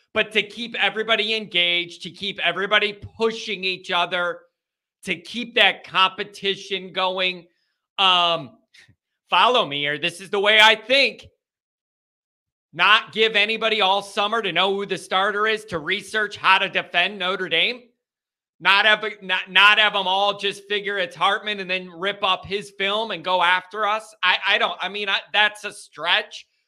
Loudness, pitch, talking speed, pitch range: -20 LUFS, 195 Hz, 165 wpm, 185-210 Hz